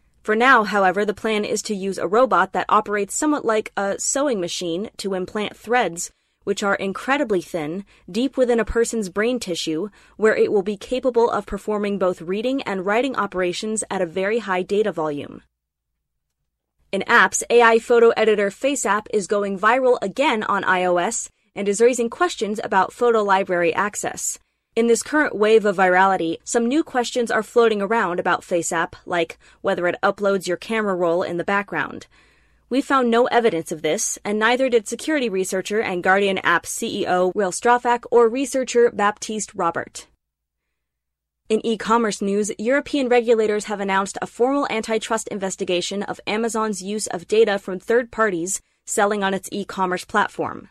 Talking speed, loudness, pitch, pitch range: 165 wpm, -20 LUFS, 210 Hz, 185-235 Hz